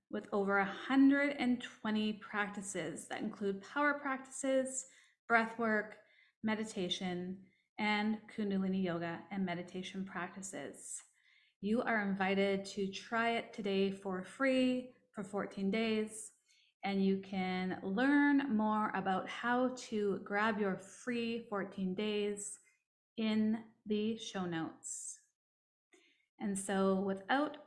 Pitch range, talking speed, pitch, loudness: 195-235 Hz, 105 wpm, 210 Hz, -36 LUFS